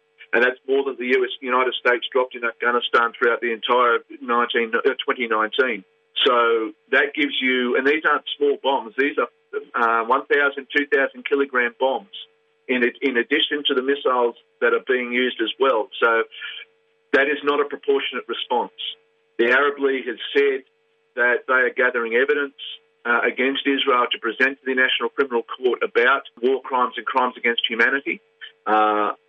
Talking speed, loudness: 160 wpm, -20 LUFS